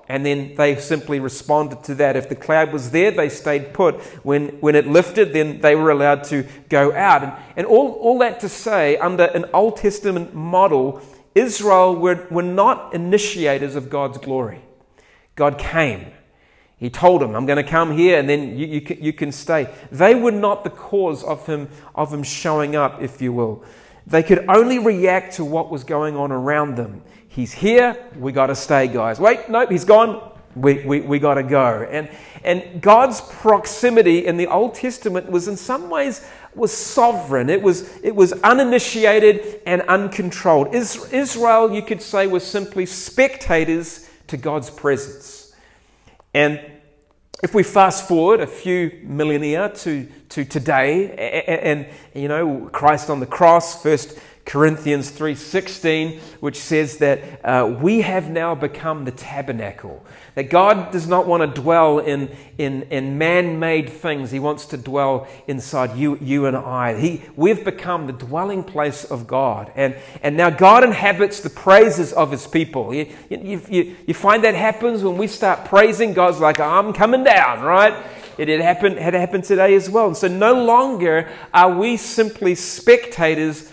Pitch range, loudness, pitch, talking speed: 145-195 Hz, -17 LUFS, 165 Hz, 170 wpm